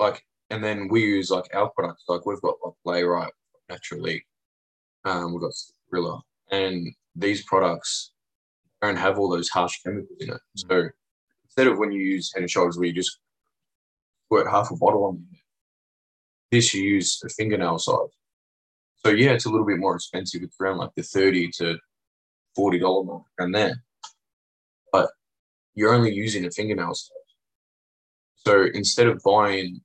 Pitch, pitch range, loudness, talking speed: 95 Hz, 85-105 Hz, -23 LUFS, 165 wpm